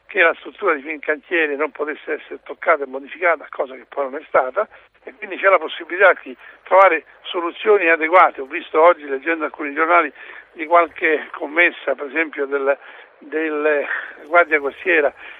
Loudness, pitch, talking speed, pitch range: -18 LUFS, 155 Hz, 165 wpm, 145-170 Hz